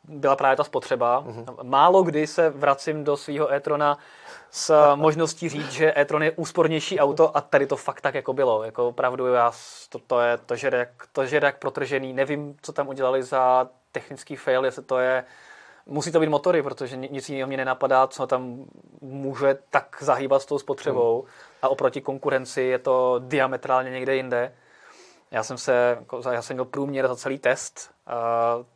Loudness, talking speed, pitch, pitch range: -23 LUFS, 175 wpm, 135 Hz, 130-150 Hz